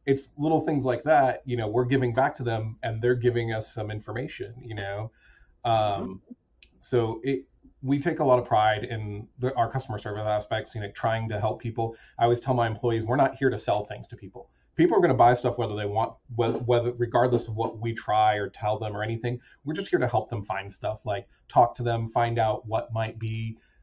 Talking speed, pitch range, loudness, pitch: 230 wpm, 110-125 Hz, -27 LUFS, 115 Hz